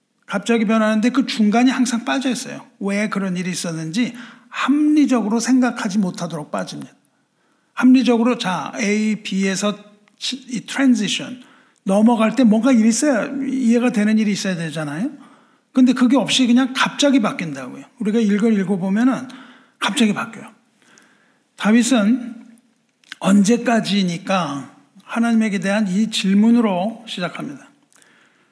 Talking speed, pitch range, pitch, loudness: 300 characters per minute, 205-255 Hz, 230 Hz, -18 LUFS